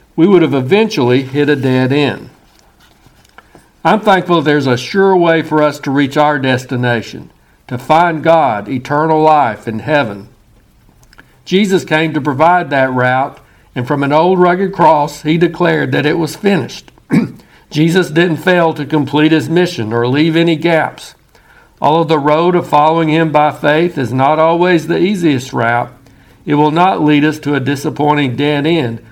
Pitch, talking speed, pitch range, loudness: 150 Hz, 165 wpm, 135-165 Hz, -12 LUFS